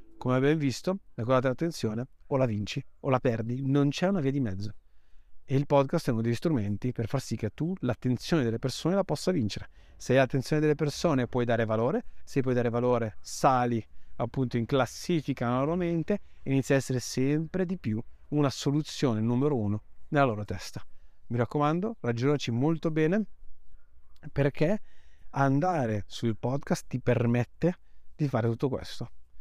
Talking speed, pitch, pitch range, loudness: 170 wpm, 130 Hz, 115-150 Hz, -29 LUFS